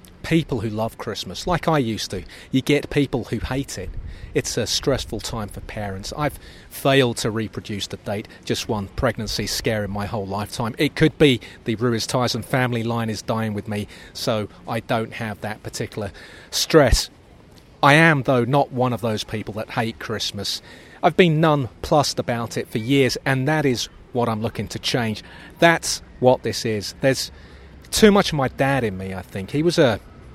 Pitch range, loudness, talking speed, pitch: 105-135 Hz, -22 LUFS, 190 wpm, 115 Hz